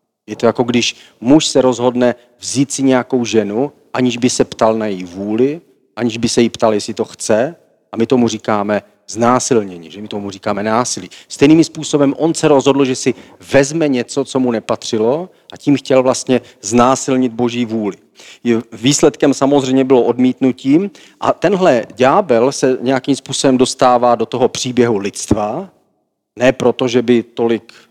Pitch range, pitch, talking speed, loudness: 115-135 Hz, 125 Hz, 160 wpm, -14 LUFS